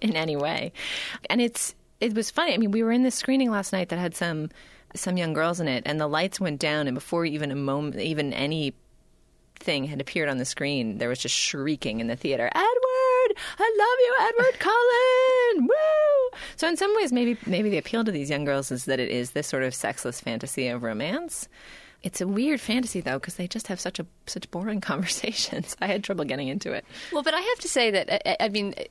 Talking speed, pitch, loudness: 230 wpm, 190 Hz, -25 LUFS